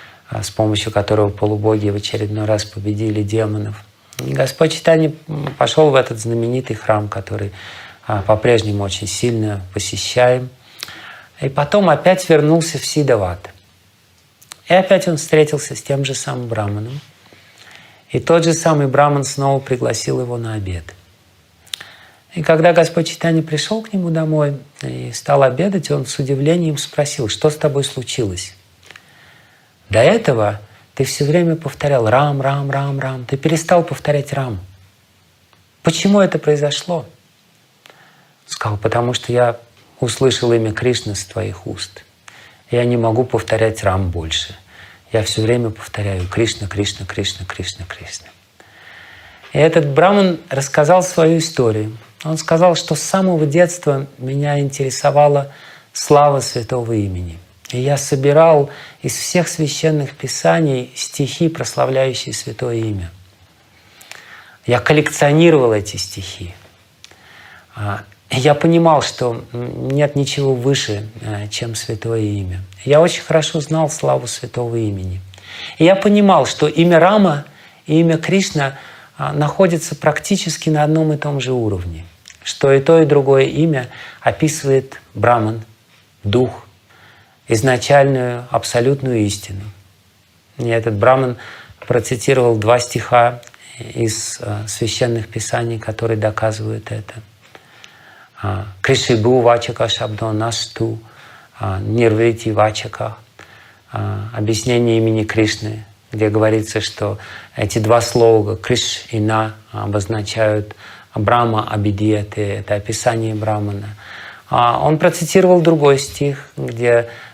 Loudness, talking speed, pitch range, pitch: -16 LUFS, 115 wpm, 105-145 Hz, 120 Hz